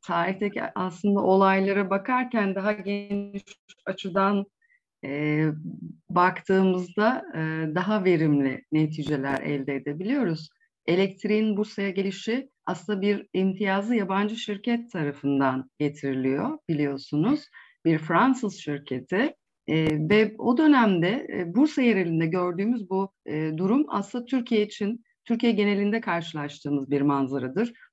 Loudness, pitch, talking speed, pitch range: -25 LUFS, 195 Hz, 100 wpm, 155-215 Hz